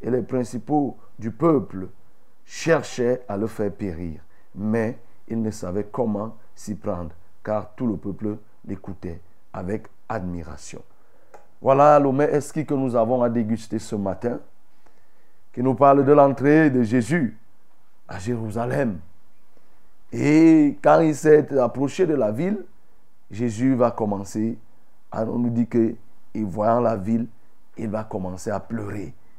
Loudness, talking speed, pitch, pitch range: -22 LUFS, 135 wpm, 115 Hz, 105-130 Hz